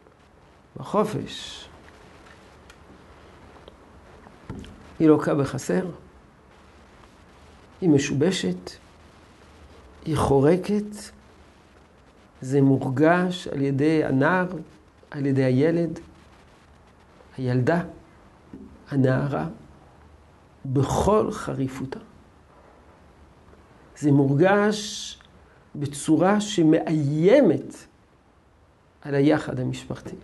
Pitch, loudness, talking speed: 140 Hz, -23 LUFS, 55 wpm